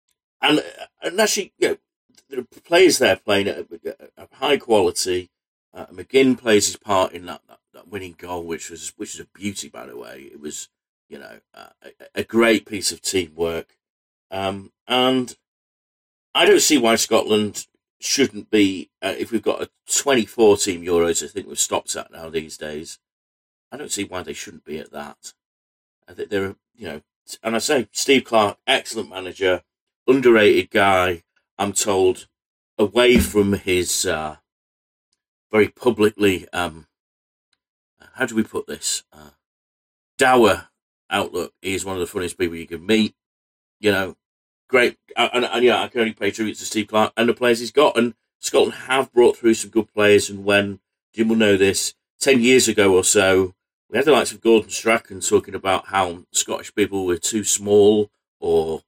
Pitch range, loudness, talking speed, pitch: 90-115 Hz, -19 LUFS, 180 wpm, 100 Hz